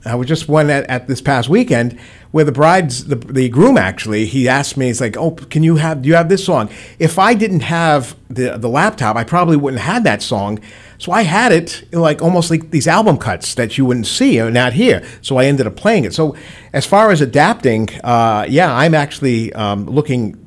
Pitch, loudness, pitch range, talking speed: 140 Hz, -14 LUFS, 120-165 Hz, 235 wpm